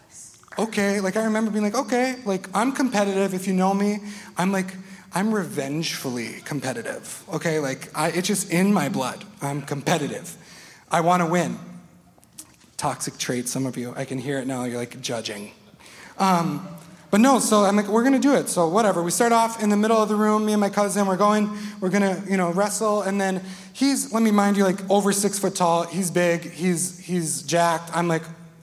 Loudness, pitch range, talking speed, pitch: -23 LUFS, 170-210 Hz, 205 wpm, 190 Hz